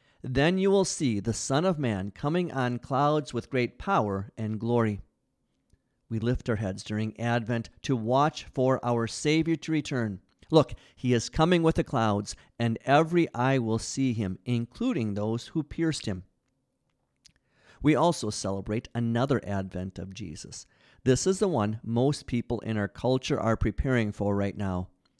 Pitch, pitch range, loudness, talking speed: 120 Hz, 105-140 Hz, -28 LUFS, 160 wpm